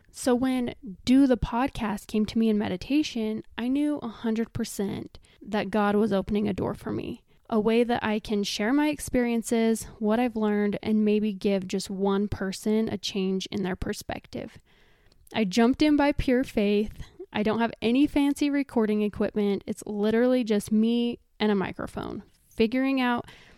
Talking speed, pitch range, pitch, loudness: 170 wpm, 210-245 Hz, 220 Hz, -26 LUFS